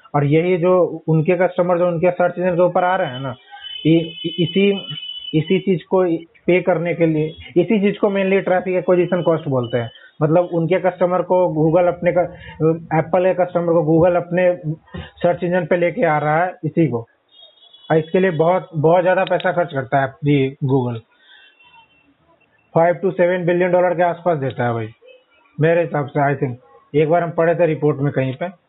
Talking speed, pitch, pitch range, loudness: 190 wpm, 175 Hz, 155-180 Hz, -18 LUFS